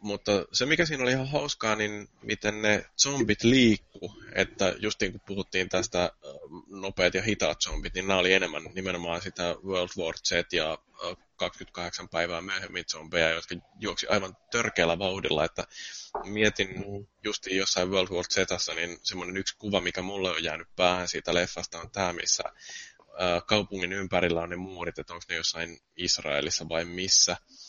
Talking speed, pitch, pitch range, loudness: 160 wpm, 95 Hz, 85-105 Hz, -28 LUFS